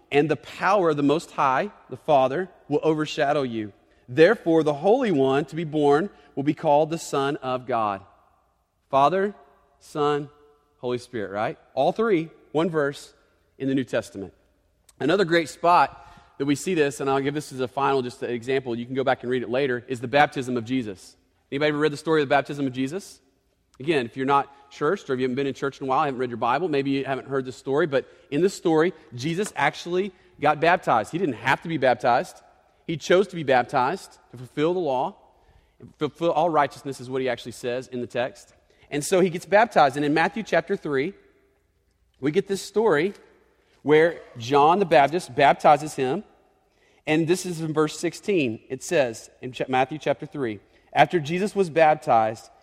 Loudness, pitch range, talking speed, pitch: -23 LUFS, 130-165 Hz, 200 wpm, 145 Hz